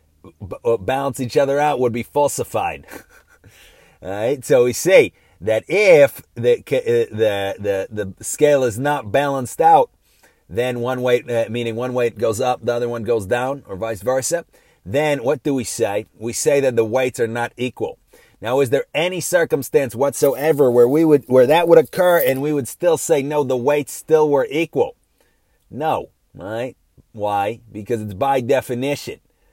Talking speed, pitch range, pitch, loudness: 175 wpm, 120-150 Hz, 130 Hz, -18 LUFS